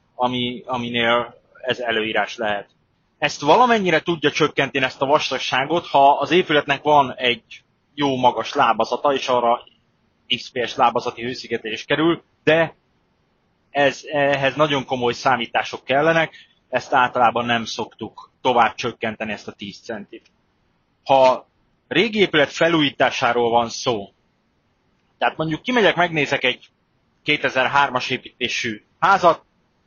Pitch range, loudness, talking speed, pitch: 120-150 Hz, -19 LUFS, 115 wpm, 135 Hz